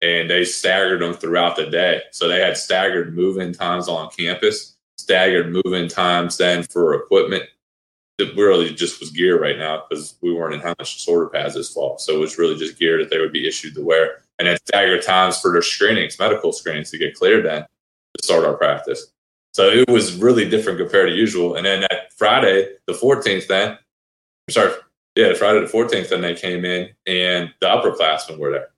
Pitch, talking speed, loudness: 390 Hz, 205 wpm, -18 LUFS